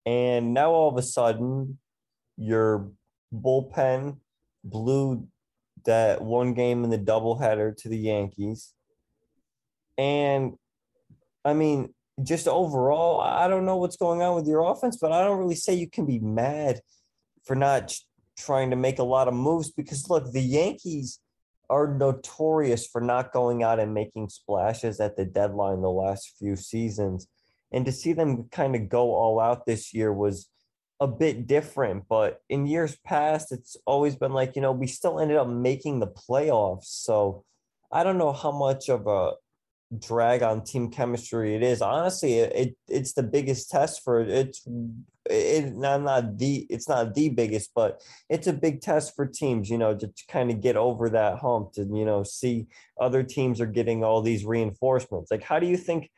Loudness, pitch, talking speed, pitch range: -26 LUFS, 125 Hz, 180 wpm, 115-145 Hz